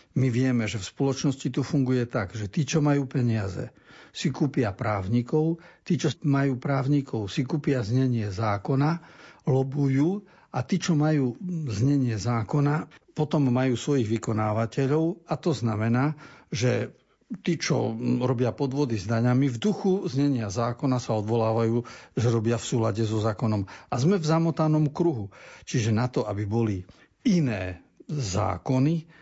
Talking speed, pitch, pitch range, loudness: 140 wpm, 130 Hz, 115-155 Hz, -26 LUFS